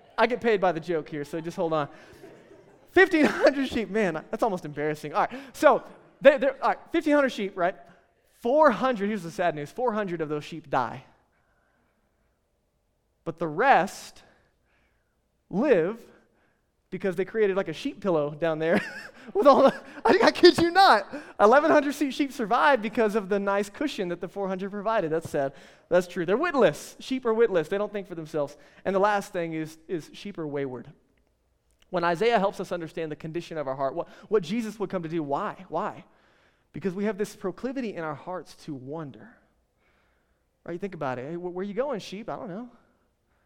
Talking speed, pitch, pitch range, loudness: 180 wpm, 195 Hz, 160-235 Hz, -26 LUFS